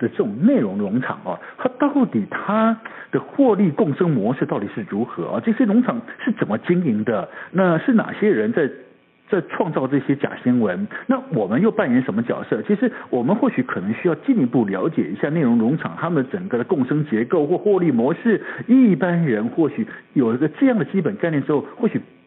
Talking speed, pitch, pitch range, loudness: 300 characters per minute, 220 Hz, 185-245 Hz, -20 LUFS